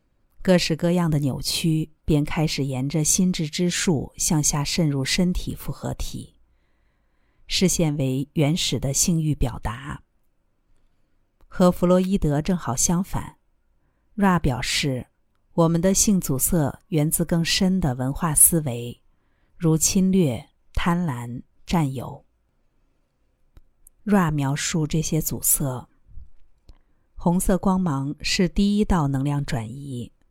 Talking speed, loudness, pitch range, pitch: 180 characters per minute, -22 LUFS, 130-175 Hz, 155 Hz